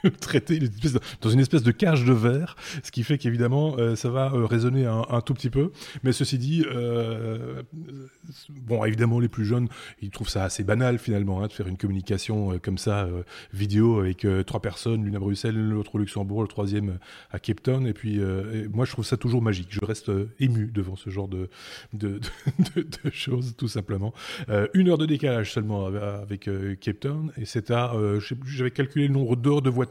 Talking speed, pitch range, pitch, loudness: 220 wpm, 105-130 Hz, 115 Hz, -26 LUFS